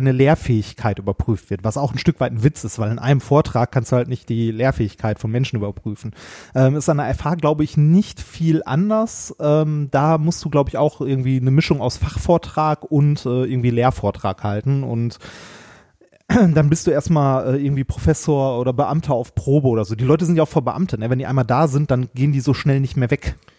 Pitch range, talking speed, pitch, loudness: 120-150 Hz, 220 wpm, 135 Hz, -19 LUFS